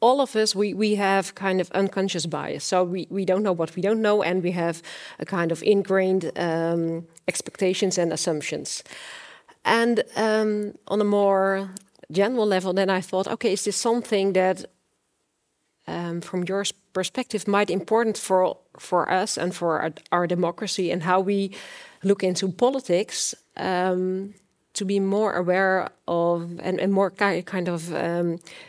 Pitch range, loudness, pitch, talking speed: 175-200 Hz, -24 LUFS, 190 Hz, 165 wpm